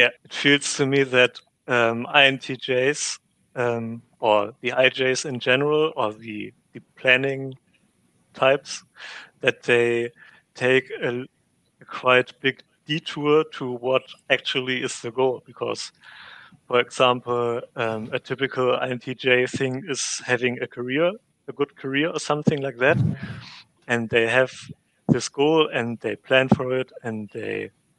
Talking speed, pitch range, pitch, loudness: 135 wpm, 120-135 Hz, 130 Hz, -22 LUFS